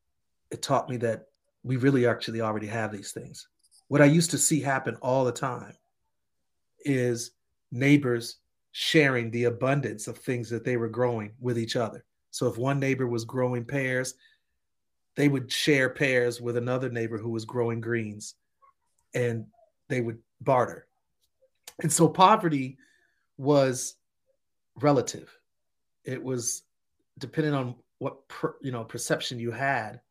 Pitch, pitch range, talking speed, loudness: 125 Hz, 115-140 Hz, 145 wpm, -27 LUFS